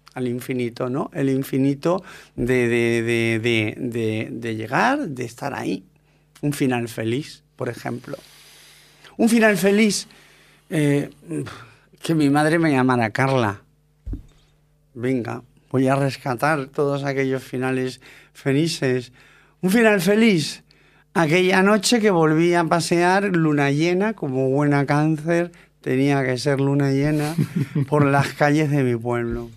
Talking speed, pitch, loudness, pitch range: 130 wpm, 140 Hz, -21 LUFS, 130-160 Hz